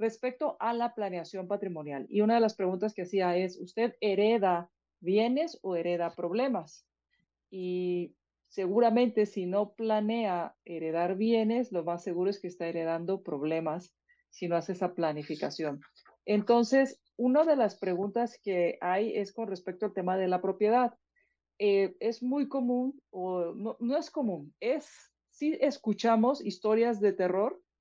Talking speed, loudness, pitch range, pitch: 150 wpm, -30 LUFS, 180-235 Hz, 205 Hz